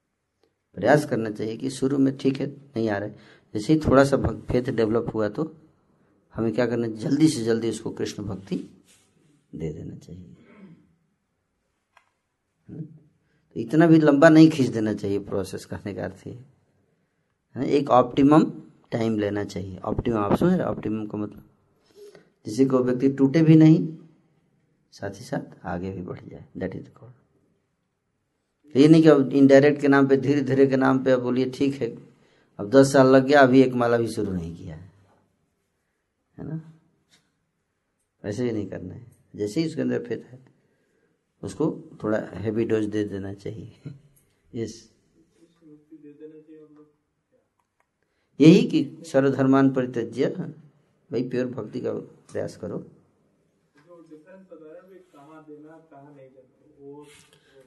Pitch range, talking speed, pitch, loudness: 110-150 Hz, 140 wpm, 135 Hz, -22 LUFS